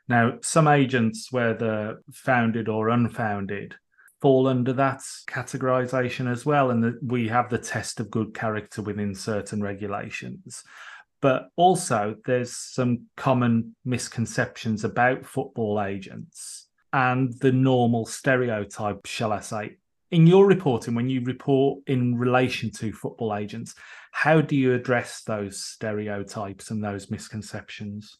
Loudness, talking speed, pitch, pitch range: -24 LUFS, 130 wpm, 120 Hz, 110-130 Hz